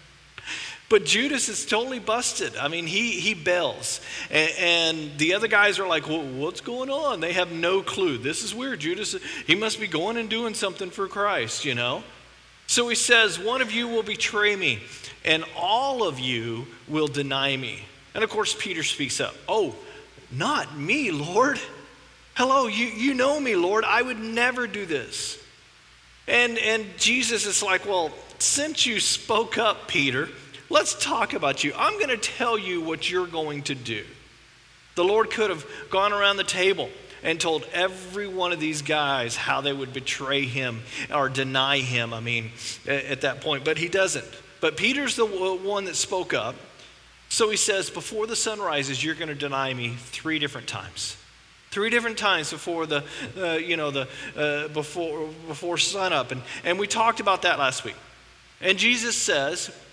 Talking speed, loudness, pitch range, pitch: 180 wpm, -24 LUFS, 145-220 Hz, 180 Hz